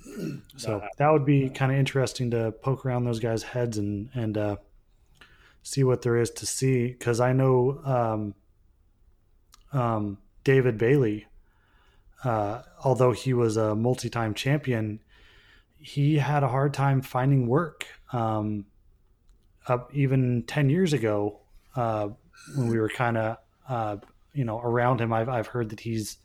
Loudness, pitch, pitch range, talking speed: -26 LUFS, 120 Hz, 105-130 Hz, 150 wpm